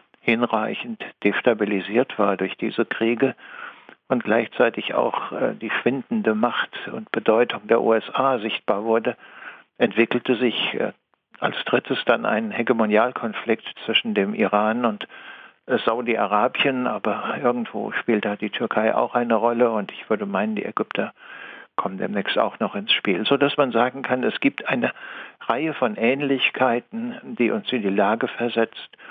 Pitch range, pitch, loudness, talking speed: 110-125 Hz, 120 Hz, -22 LUFS, 140 wpm